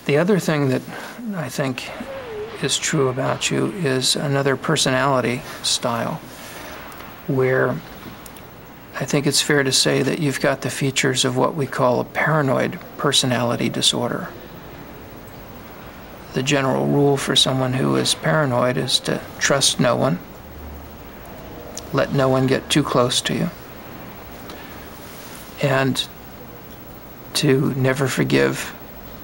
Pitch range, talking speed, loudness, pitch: 130-145 Hz, 120 wpm, -19 LUFS, 135 Hz